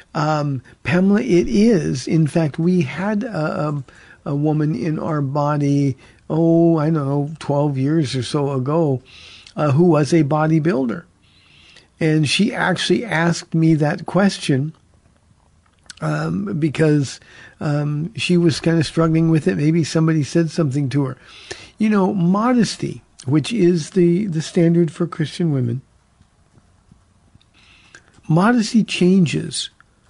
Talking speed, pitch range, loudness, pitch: 130 wpm, 145-175 Hz, -18 LUFS, 160 Hz